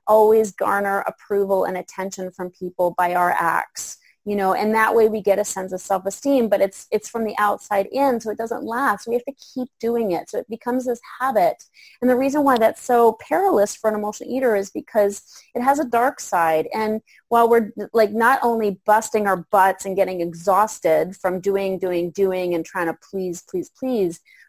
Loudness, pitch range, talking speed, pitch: -21 LUFS, 190-235 Hz, 205 wpm, 210 Hz